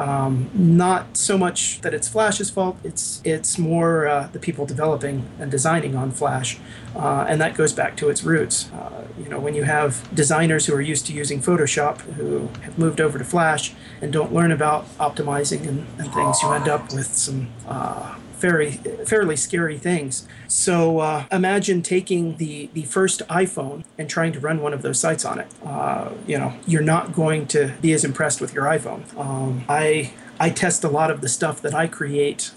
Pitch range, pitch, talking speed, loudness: 140-165 Hz, 155 Hz, 195 wpm, -21 LUFS